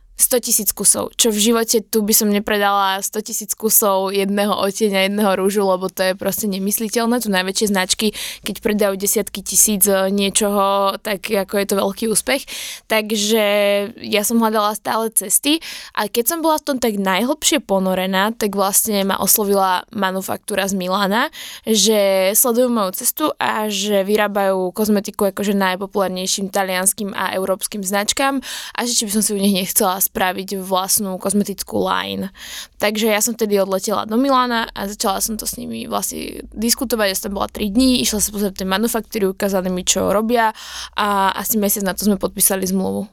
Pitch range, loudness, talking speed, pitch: 195-220 Hz, -17 LUFS, 170 wpm, 205 Hz